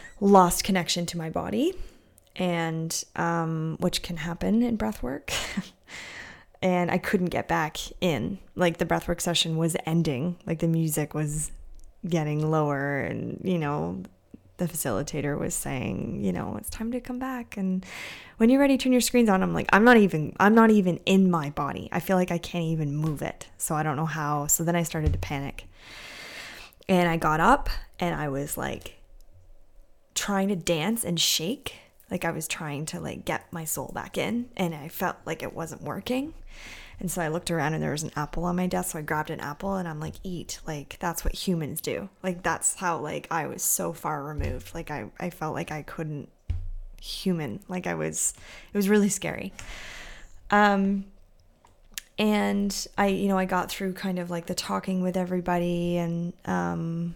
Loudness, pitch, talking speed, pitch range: -27 LUFS, 175 Hz, 190 wpm, 155-190 Hz